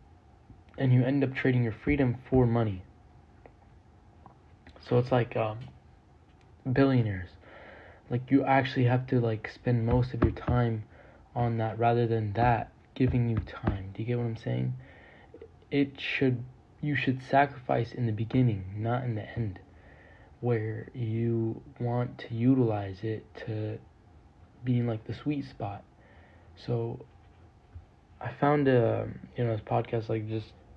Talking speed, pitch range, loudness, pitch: 145 wpm, 105-125 Hz, -29 LUFS, 115 Hz